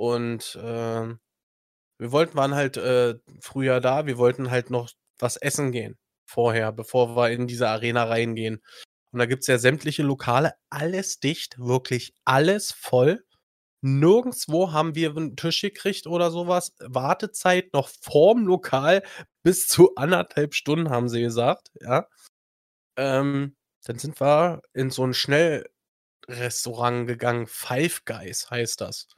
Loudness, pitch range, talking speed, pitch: -23 LUFS, 120-155 Hz, 140 wpm, 130 Hz